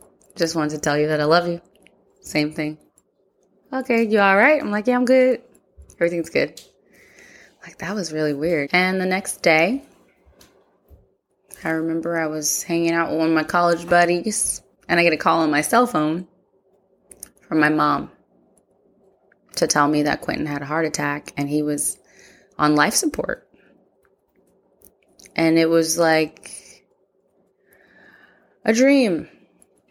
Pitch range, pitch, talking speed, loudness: 155-195 Hz, 170 Hz, 150 wpm, -20 LUFS